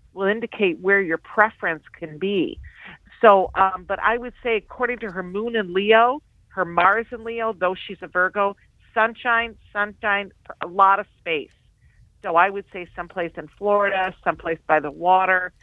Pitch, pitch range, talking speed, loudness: 200 Hz, 185-225 Hz, 170 wpm, -21 LUFS